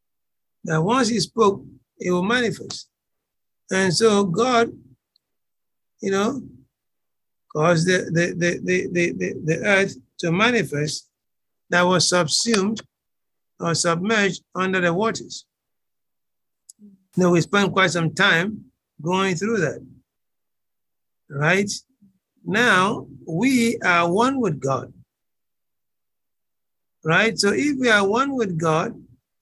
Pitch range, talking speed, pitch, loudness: 165-215 Hz, 110 wpm, 185 Hz, -20 LUFS